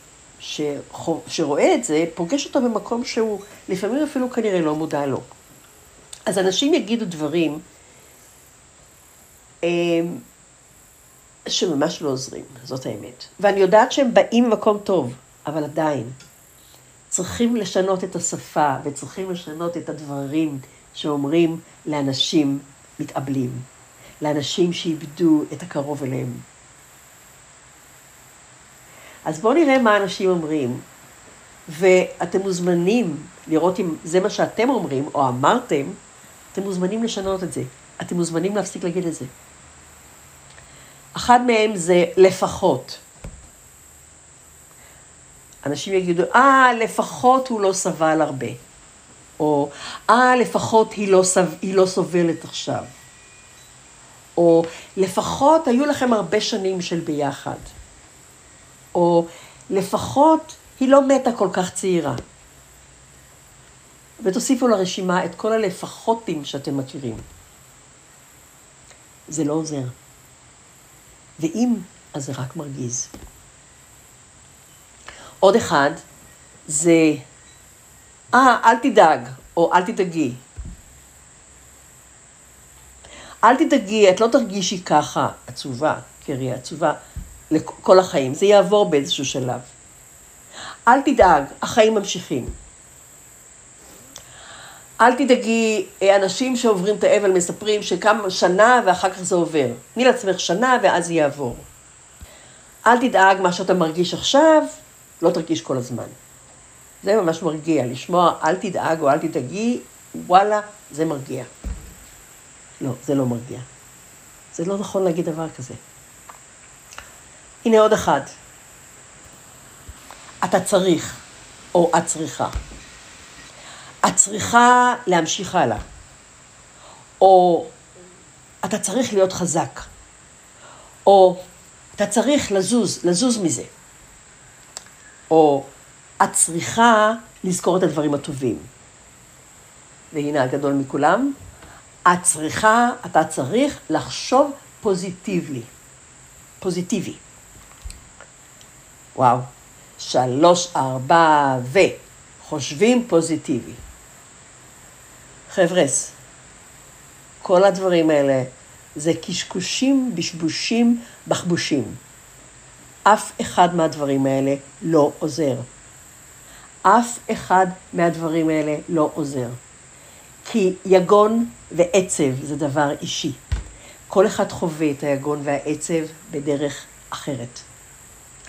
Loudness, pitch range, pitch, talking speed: -19 LUFS, 145-205 Hz, 170 Hz, 95 wpm